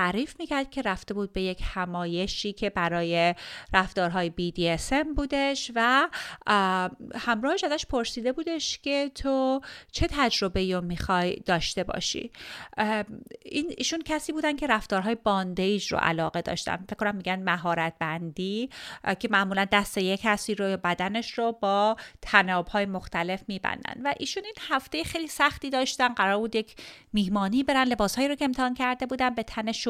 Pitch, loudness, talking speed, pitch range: 215 Hz, -27 LUFS, 150 wpm, 190-270 Hz